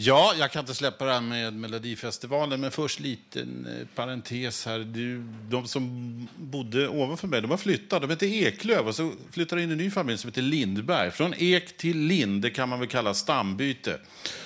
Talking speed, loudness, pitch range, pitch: 195 wpm, -28 LUFS, 120-160 Hz, 130 Hz